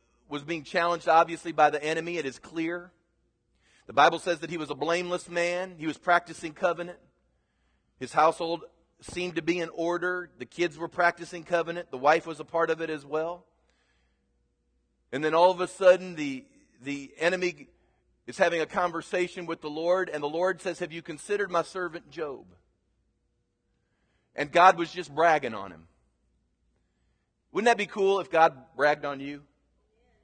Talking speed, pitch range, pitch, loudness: 170 wpm, 150-175 Hz, 165 Hz, -27 LUFS